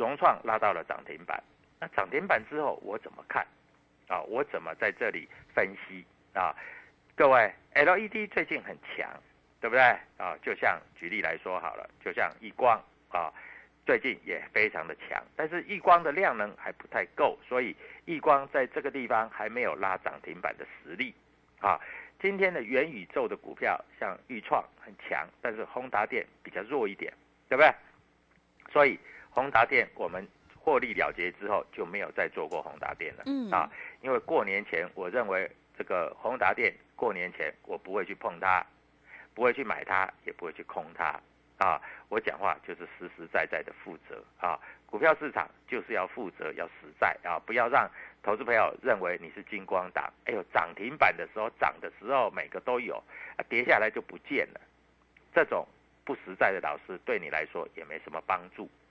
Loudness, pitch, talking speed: -30 LUFS, 320 Hz, 265 characters per minute